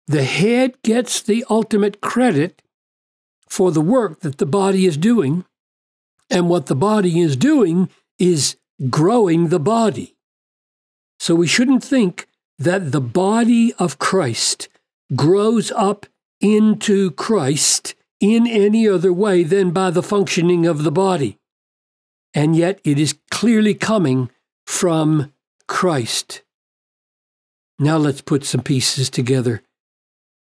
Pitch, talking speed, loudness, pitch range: 185 Hz, 120 wpm, -17 LUFS, 155-215 Hz